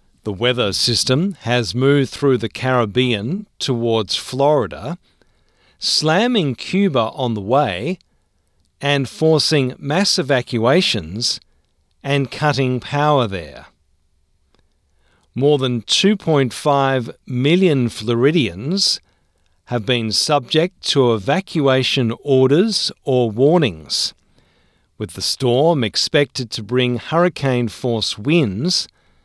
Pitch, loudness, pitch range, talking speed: 125 Hz, -17 LUFS, 110-145 Hz, 90 wpm